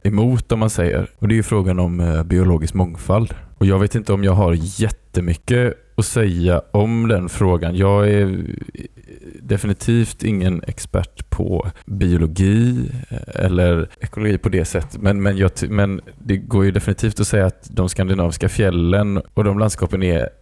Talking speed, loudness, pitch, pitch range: 160 wpm, -18 LUFS, 100 Hz, 90-110 Hz